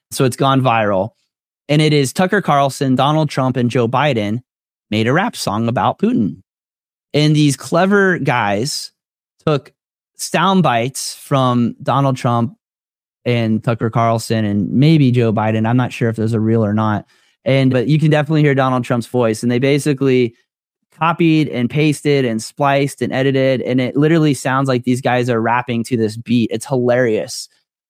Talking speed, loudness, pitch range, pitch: 170 wpm, -16 LUFS, 115-145 Hz, 130 Hz